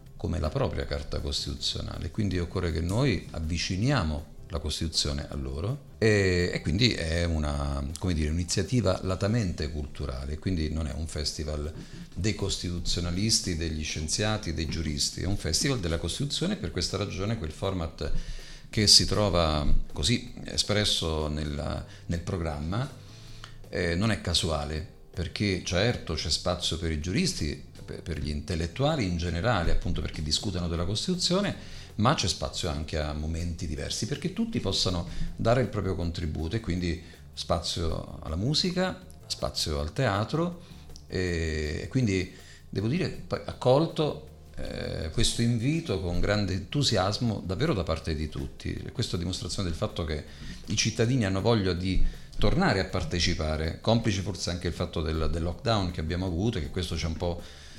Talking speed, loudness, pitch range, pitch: 150 wpm, -29 LUFS, 80-105 Hz, 90 Hz